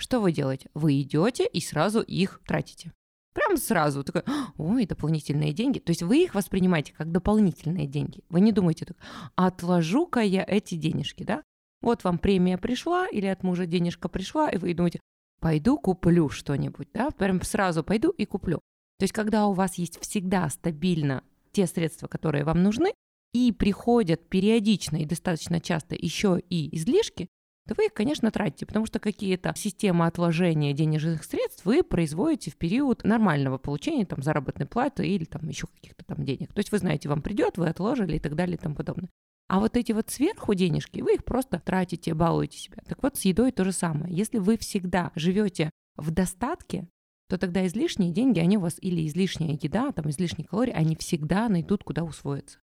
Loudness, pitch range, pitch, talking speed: -26 LUFS, 165-210 Hz, 185 Hz, 180 wpm